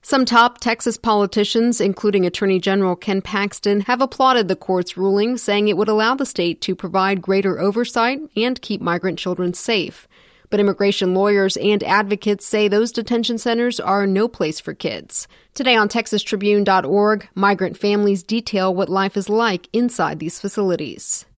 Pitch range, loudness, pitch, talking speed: 195-230 Hz, -18 LUFS, 205 Hz, 155 wpm